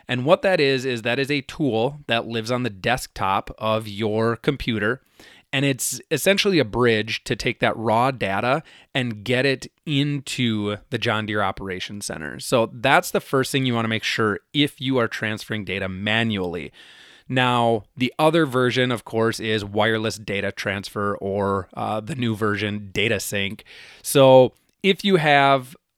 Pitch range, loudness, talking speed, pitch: 110-135 Hz, -22 LUFS, 170 wpm, 120 Hz